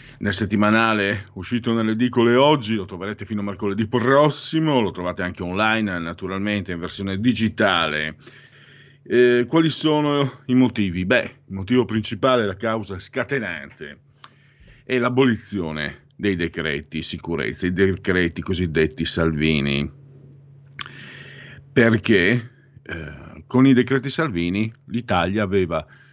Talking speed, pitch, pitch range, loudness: 115 wpm, 110 Hz, 90-125 Hz, -21 LUFS